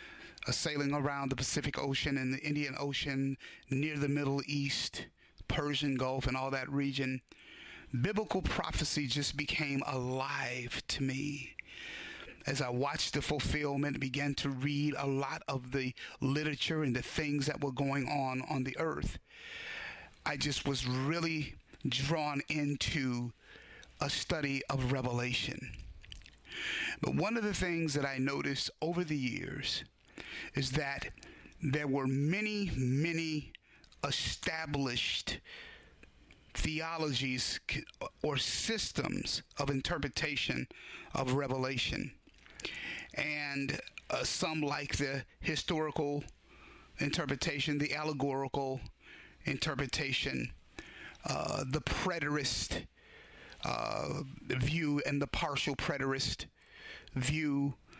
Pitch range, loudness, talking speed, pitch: 130-150 Hz, -35 LUFS, 110 wpm, 140 Hz